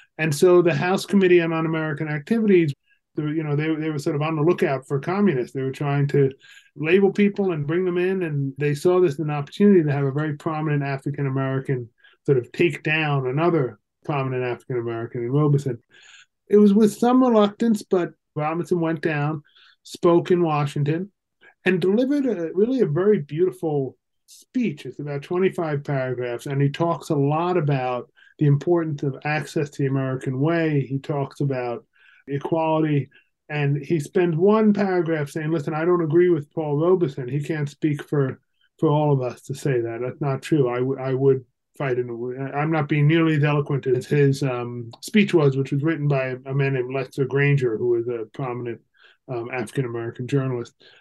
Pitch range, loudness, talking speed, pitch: 135-175 Hz, -22 LUFS, 185 wpm, 150 Hz